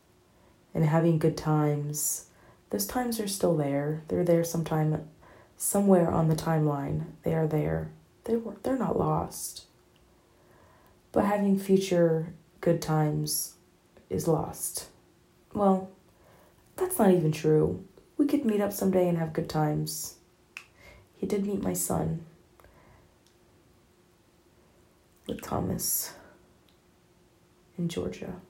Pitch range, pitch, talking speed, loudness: 155-195 Hz, 165 Hz, 115 wpm, -28 LUFS